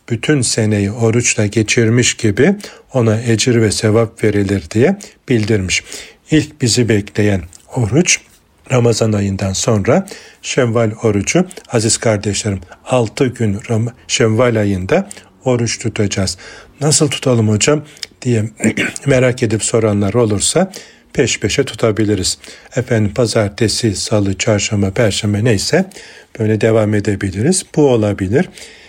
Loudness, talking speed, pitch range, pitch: -15 LUFS, 105 wpm, 105-120 Hz, 110 Hz